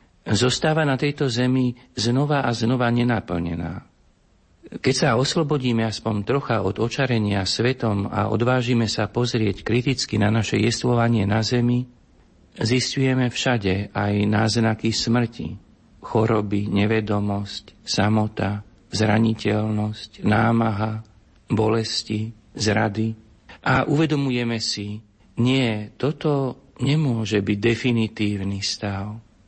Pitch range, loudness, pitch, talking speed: 105-125 Hz, -22 LUFS, 110 Hz, 95 wpm